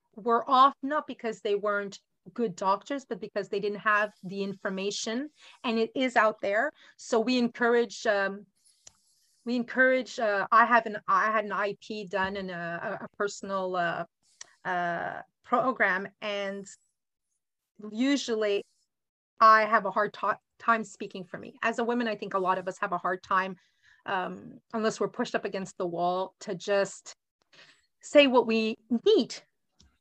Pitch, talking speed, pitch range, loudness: 210 Hz, 160 wpm, 195-235 Hz, -28 LUFS